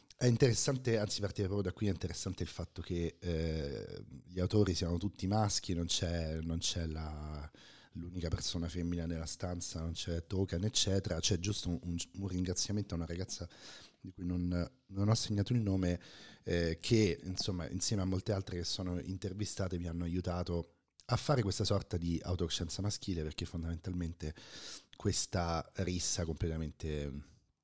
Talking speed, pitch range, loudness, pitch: 160 wpm, 85-100 Hz, -36 LUFS, 90 Hz